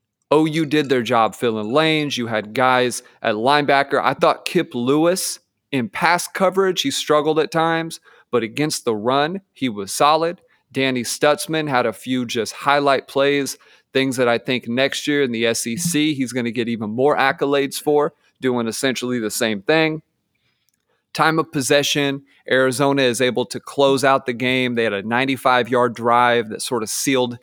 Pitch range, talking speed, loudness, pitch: 125-150 Hz, 175 wpm, -19 LUFS, 135 Hz